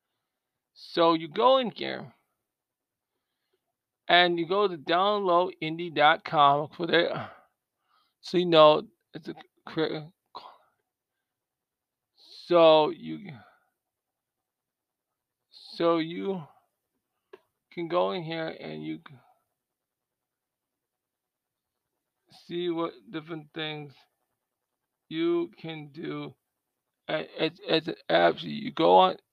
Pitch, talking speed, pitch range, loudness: 160 Hz, 90 wpm, 125-175 Hz, -25 LUFS